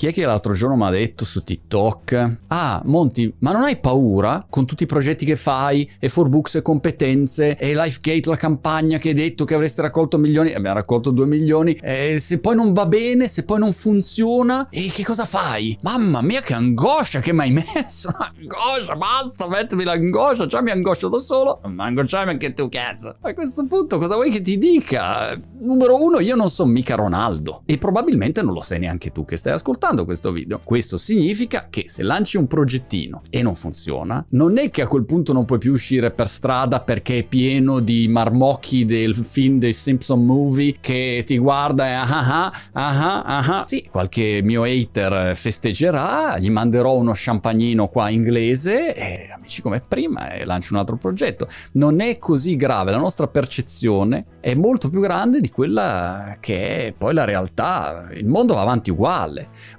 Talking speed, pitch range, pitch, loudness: 190 wpm, 115-165 Hz, 135 Hz, -19 LUFS